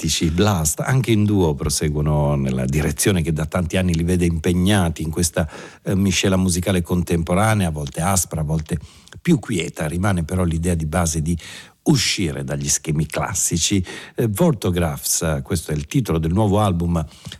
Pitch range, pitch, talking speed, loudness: 80-95 Hz, 85 Hz, 160 wpm, -20 LUFS